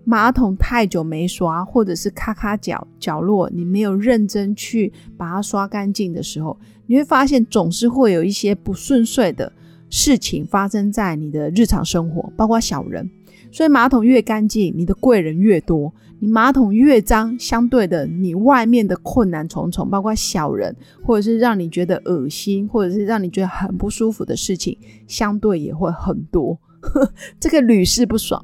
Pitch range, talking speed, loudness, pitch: 180-230 Hz, 265 characters per minute, -17 LUFS, 205 Hz